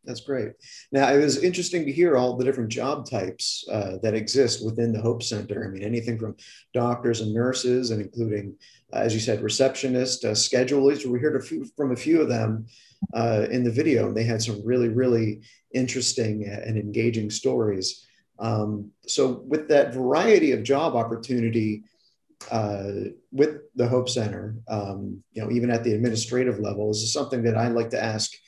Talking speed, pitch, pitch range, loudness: 185 wpm, 115 Hz, 110-125 Hz, -24 LUFS